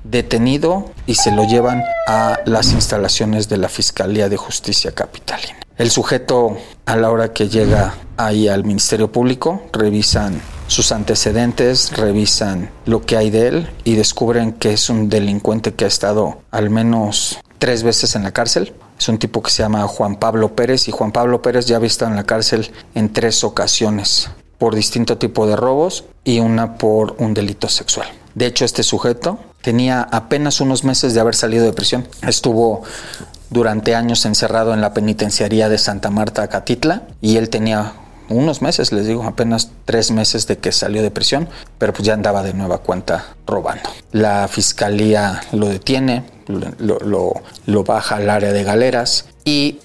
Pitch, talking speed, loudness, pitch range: 110 Hz, 170 wpm, -16 LUFS, 105-120 Hz